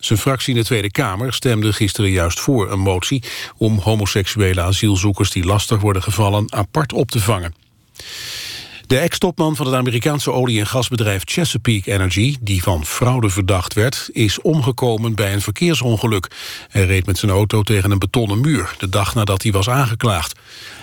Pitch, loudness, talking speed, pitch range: 110 Hz, -17 LUFS, 165 wpm, 100-125 Hz